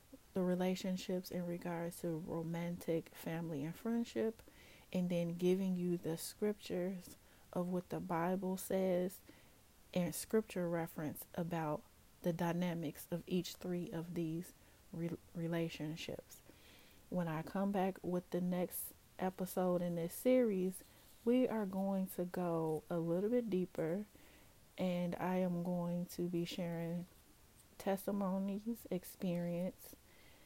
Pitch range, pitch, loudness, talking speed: 170-190 Hz, 180 Hz, -40 LUFS, 120 wpm